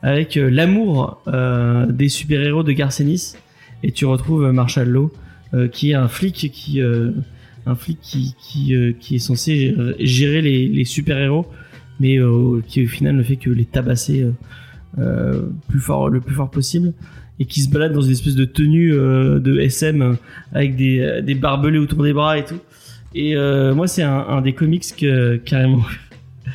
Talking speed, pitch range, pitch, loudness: 190 wpm, 125-150 Hz, 135 Hz, -17 LUFS